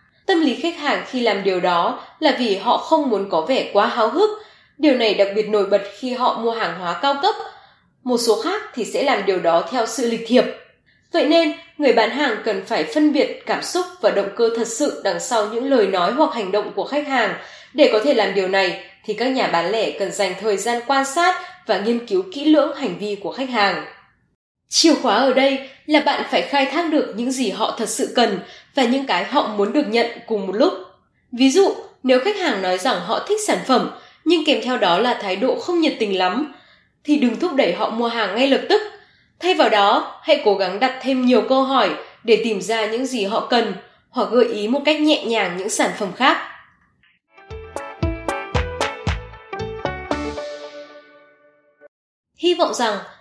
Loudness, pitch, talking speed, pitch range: -19 LUFS, 240 Hz, 210 wpm, 205-295 Hz